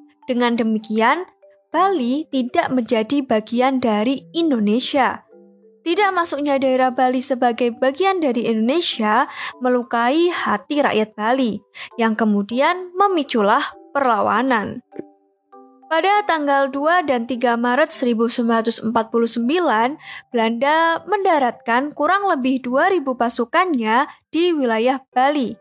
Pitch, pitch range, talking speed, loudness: 260 Hz, 230-305 Hz, 95 wpm, -19 LUFS